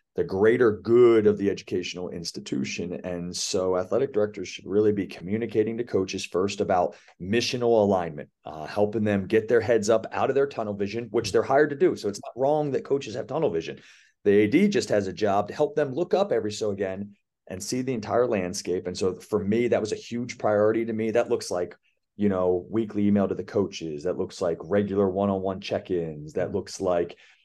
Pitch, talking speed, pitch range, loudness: 105 Hz, 215 wpm, 95-115 Hz, -25 LUFS